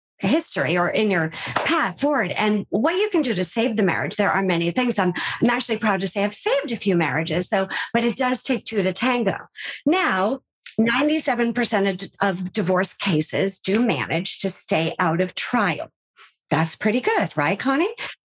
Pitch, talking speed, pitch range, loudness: 200 Hz, 180 wpm, 185-240 Hz, -22 LUFS